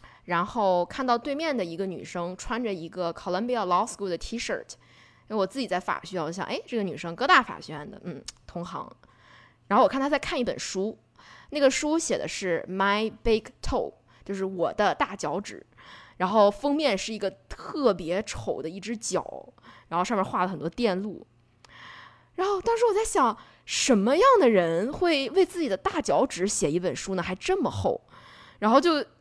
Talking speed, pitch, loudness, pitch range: 310 characters per minute, 205 Hz, -26 LUFS, 180-270 Hz